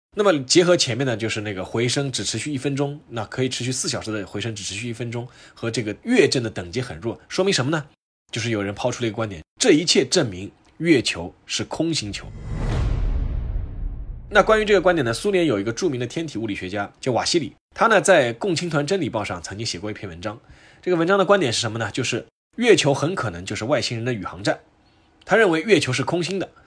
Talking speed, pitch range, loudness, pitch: 345 characters per minute, 105-145 Hz, -22 LUFS, 120 Hz